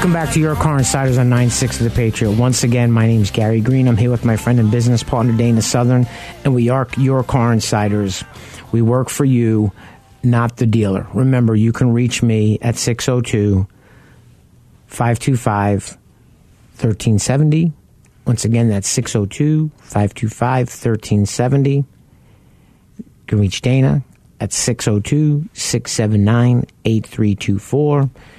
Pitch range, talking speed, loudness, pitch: 110-130 Hz, 125 wpm, -16 LUFS, 120 Hz